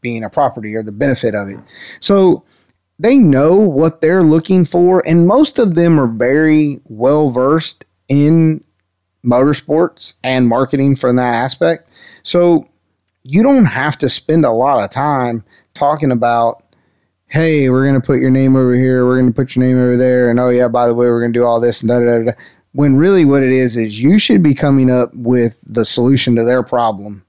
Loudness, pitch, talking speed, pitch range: -12 LUFS, 130 Hz, 200 wpm, 120-150 Hz